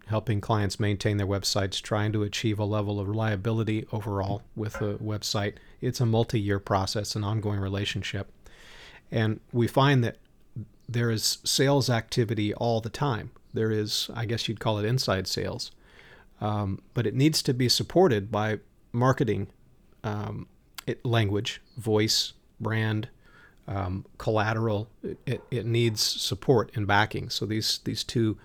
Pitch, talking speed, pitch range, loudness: 110 Hz, 150 wpm, 105-115 Hz, -27 LUFS